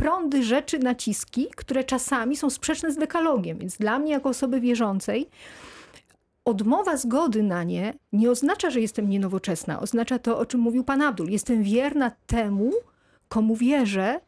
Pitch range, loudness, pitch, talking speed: 215-280 Hz, -24 LUFS, 245 Hz, 150 wpm